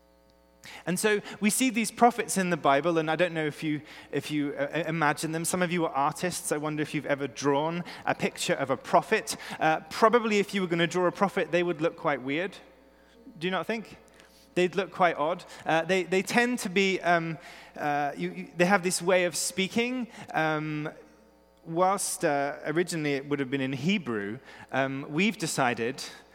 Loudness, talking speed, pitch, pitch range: -28 LUFS, 200 wpm, 170 Hz, 150-190 Hz